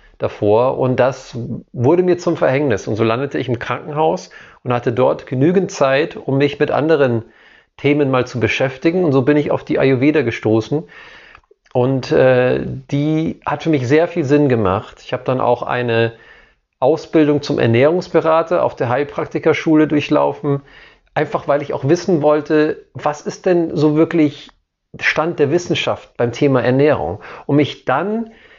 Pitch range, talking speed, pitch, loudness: 125-160 Hz, 160 wpm, 145 Hz, -16 LUFS